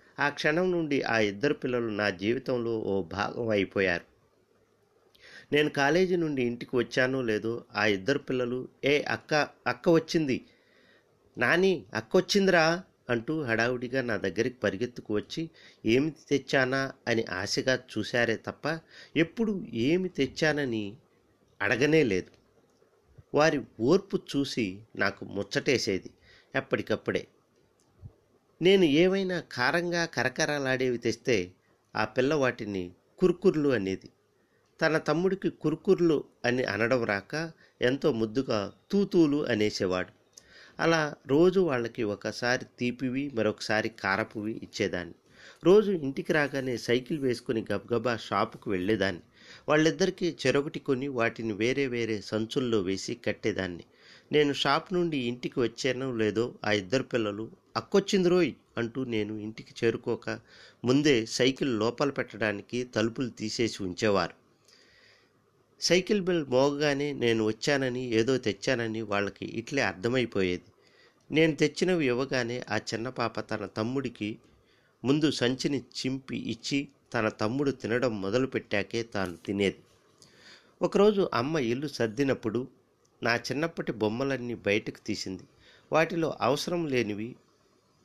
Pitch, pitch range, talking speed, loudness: 125 Hz, 110-150 Hz, 105 wpm, -28 LUFS